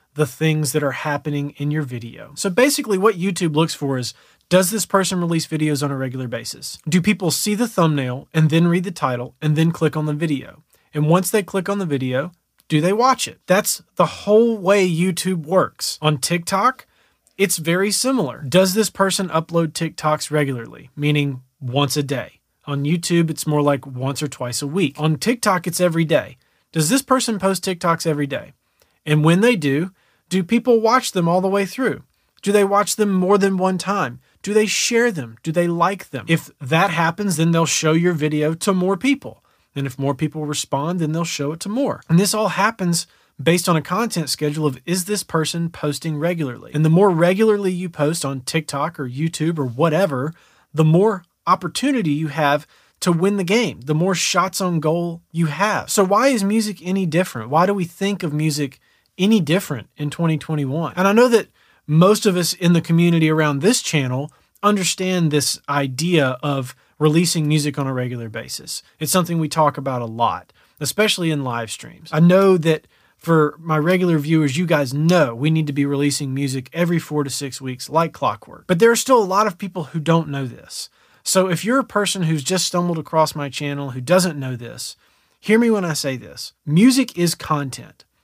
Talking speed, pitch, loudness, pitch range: 200 wpm, 165 Hz, -19 LUFS, 150-190 Hz